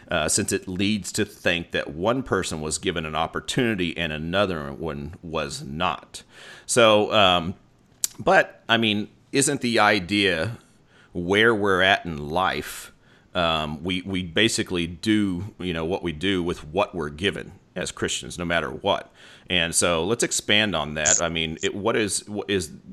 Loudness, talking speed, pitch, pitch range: -23 LUFS, 165 wpm, 95 Hz, 85-105 Hz